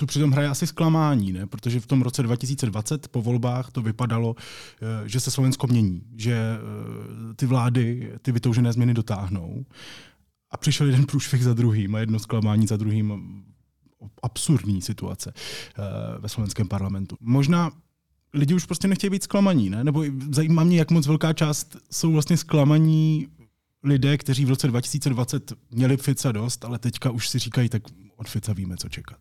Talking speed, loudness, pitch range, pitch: 160 wpm, -23 LUFS, 110-145 Hz, 125 Hz